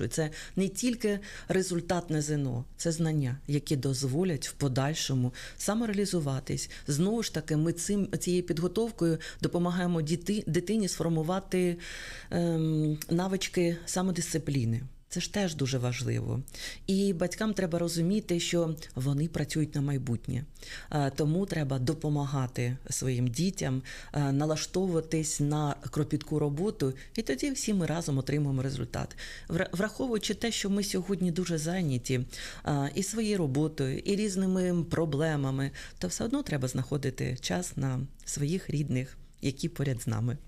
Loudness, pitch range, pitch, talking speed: -31 LUFS, 135-180 Hz, 155 Hz, 125 wpm